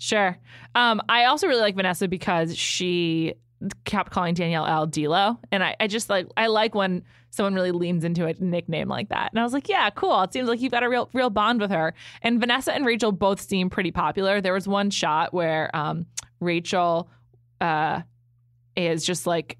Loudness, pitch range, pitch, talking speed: -24 LUFS, 165-210 Hz, 185 Hz, 200 wpm